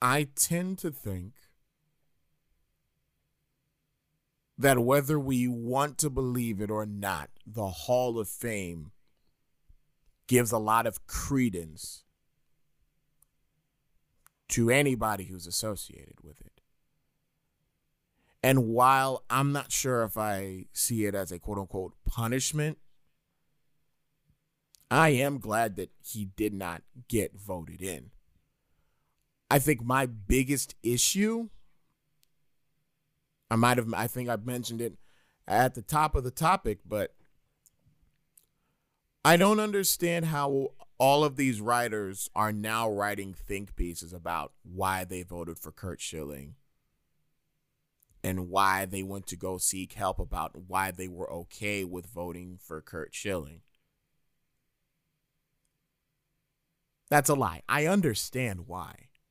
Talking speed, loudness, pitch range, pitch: 115 wpm, -29 LUFS, 95-145 Hz, 120 Hz